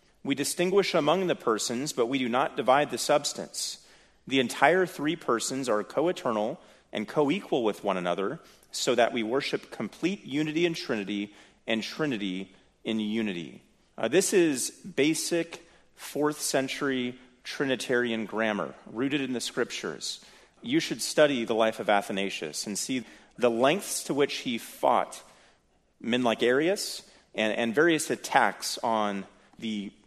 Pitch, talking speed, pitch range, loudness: 125 Hz, 145 wpm, 110-155 Hz, -28 LUFS